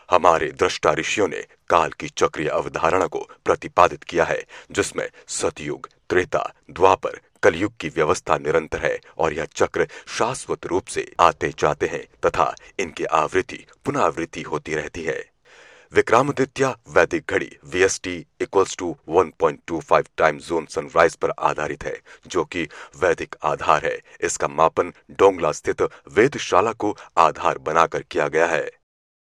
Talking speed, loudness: 145 wpm, -22 LUFS